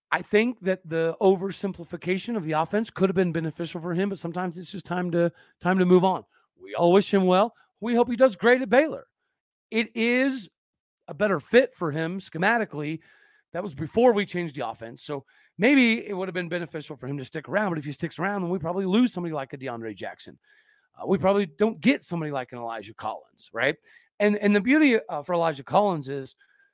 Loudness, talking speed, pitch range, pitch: -25 LUFS, 220 wpm, 165-220 Hz, 185 Hz